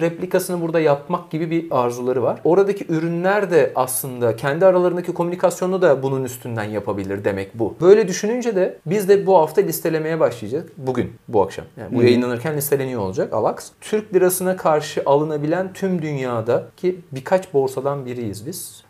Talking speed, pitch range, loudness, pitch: 150 wpm, 130-185 Hz, -20 LUFS, 160 Hz